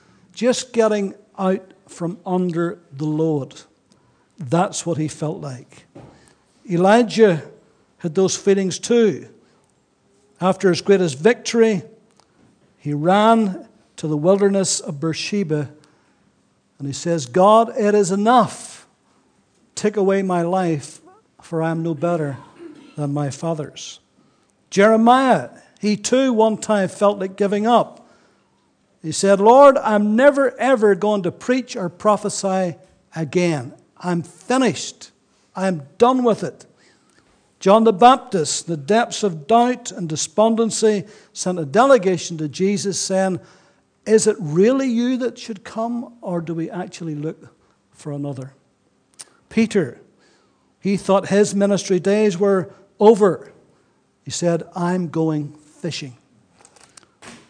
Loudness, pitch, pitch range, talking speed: -18 LUFS, 190 Hz, 165-215 Hz, 120 wpm